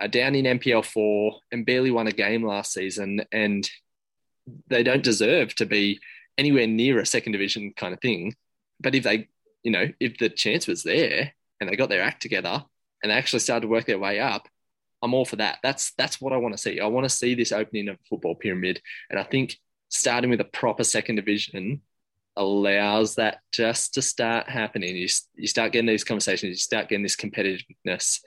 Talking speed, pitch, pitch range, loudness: 210 wpm, 110 Hz, 105-120 Hz, -24 LUFS